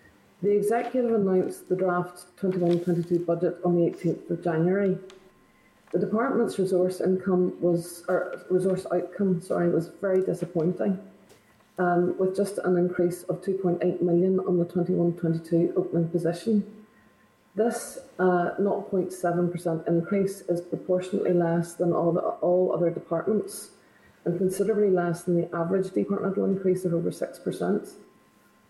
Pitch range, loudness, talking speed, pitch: 175-190 Hz, -26 LUFS, 125 wpm, 180 Hz